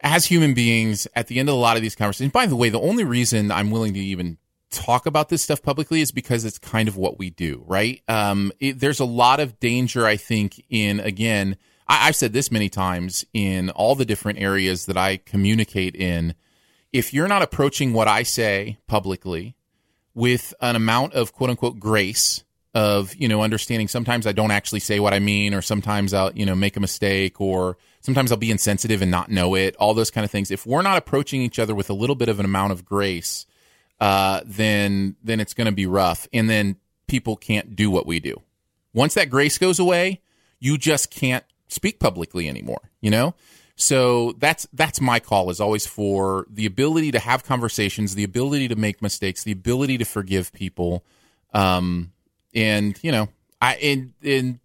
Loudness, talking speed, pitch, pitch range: -21 LUFS, 205 wpm, 110 Hz, 100-125 Hz